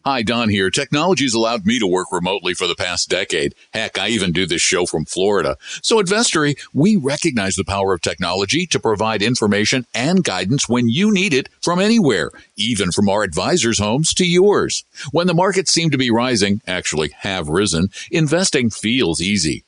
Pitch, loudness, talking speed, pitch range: 140 Hz, -17 LUFS, 185 wpm, 110-180 Hz